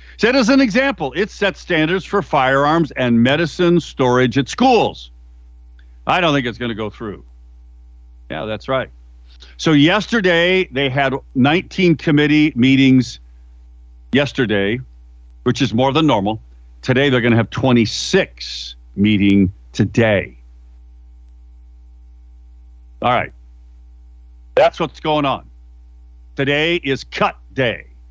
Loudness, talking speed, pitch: -16 LUFS, 120 wpm, 105 Hz